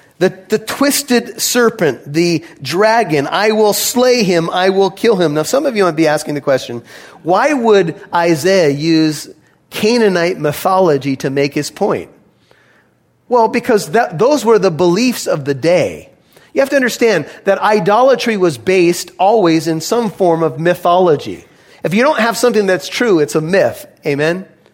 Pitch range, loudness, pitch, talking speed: 160-230 Hz, -13 LUFS, 185 Hz, 165 wpm